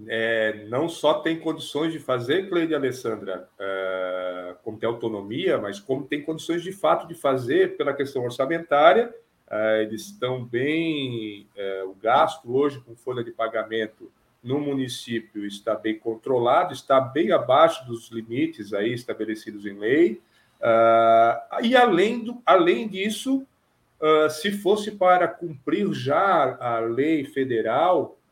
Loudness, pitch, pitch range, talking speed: -23 LUFS, 130 Hz, 115-165 Hz, 140 wpm